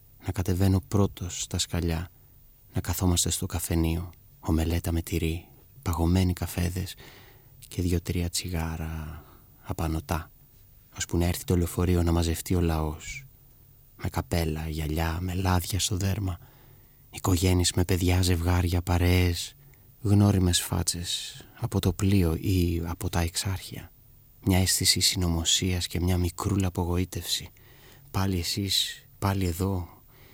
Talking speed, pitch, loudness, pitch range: 115 wpm, 90 Hz, -27 LUFS, 85-100 Hz